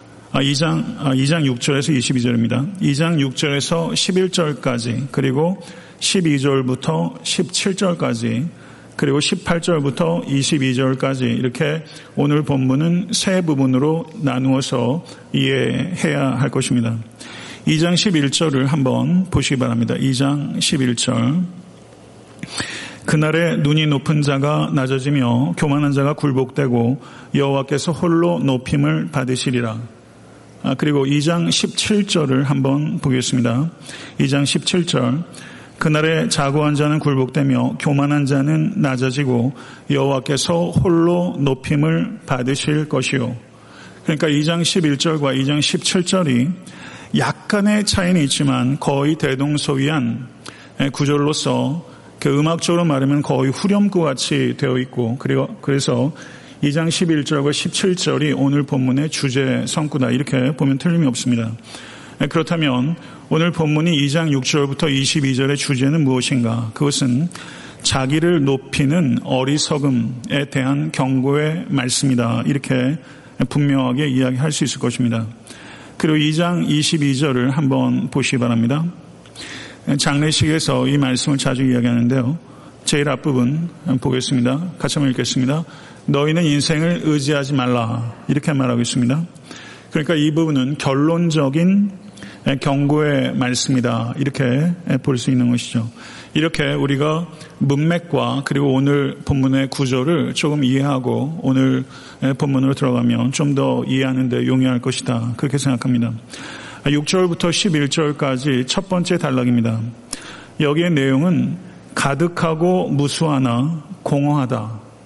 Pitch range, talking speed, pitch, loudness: 130-155 Hz, 260 characters per minute, 140 Hz, -18 LUFS